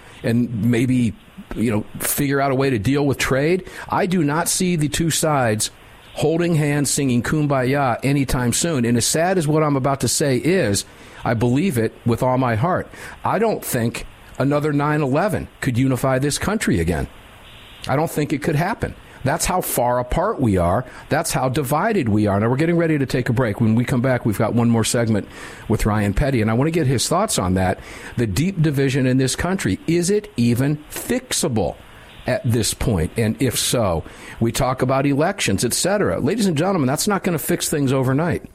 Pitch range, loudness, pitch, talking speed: 115-155 Hz, -19 LUFS, 130 Hz, 205 wpm